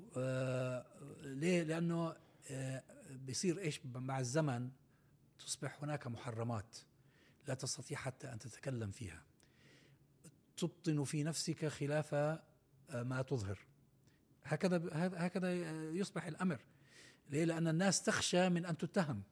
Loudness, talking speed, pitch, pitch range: -40 LUFS, 110 wpm, 145 Hz, 130-165 Hz